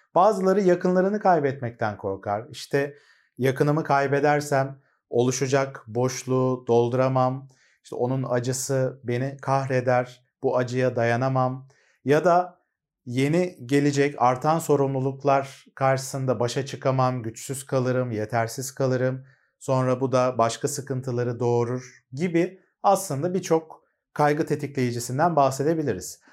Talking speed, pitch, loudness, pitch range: 100 wpm, 135 Hz, -24 LUFS, 125-145 Hz